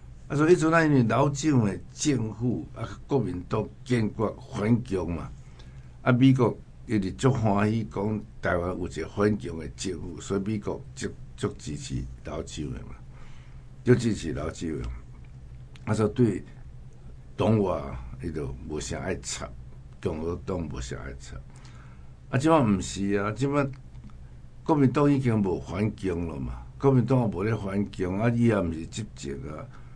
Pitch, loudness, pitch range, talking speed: 105 Hz, -27 LUFS, 80-125 Hz, 225 characters per minute